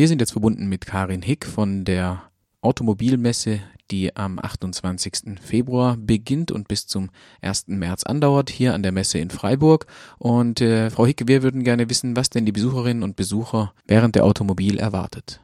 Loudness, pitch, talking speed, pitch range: -21 LUFS, 110 Hz, 175 wpm, 100-125 Hz